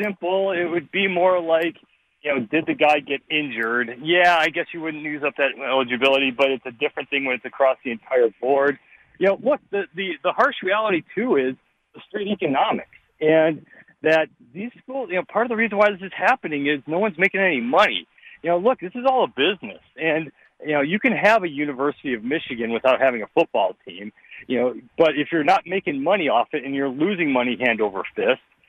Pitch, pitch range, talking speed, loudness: 160 Hz, 140-190 Hz, 220 wpm, -21 LUFS